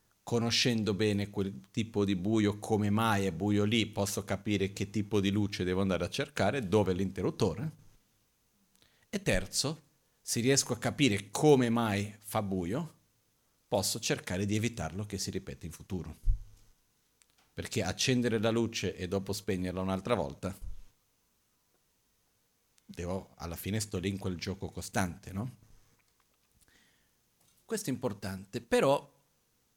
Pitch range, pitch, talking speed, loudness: 95-115 Hz, 105 Hz, 135 wpm, -32 LUFS